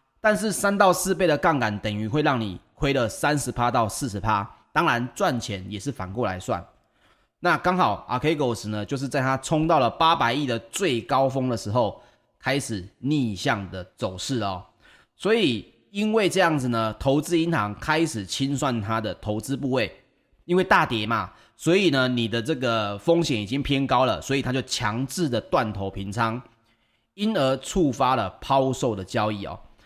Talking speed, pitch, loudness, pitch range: 265 characters per minute, 130 Hz, -24 LUFS, 115-150 Hz